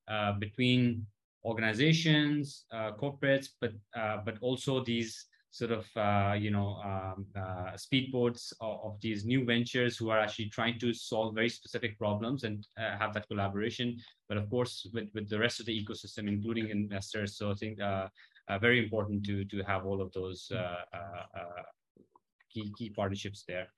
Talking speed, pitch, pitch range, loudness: 170 wpm, 110 Hz, 100-120 Hz, -34 LUFS